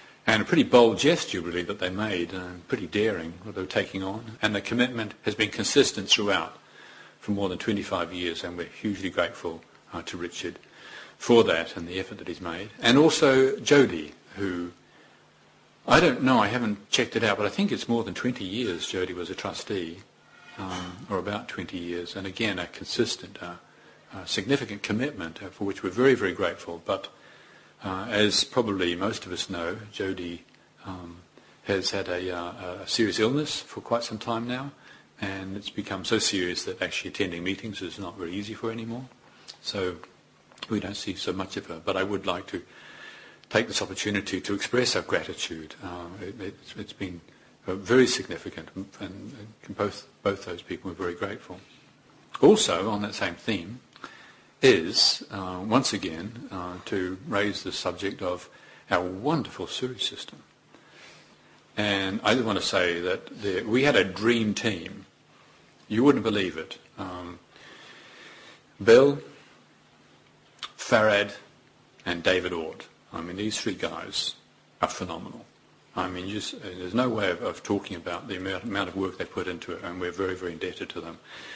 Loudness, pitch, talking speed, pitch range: -27 LUFS, 100 Hz, 170 wpm, 90-110 Hz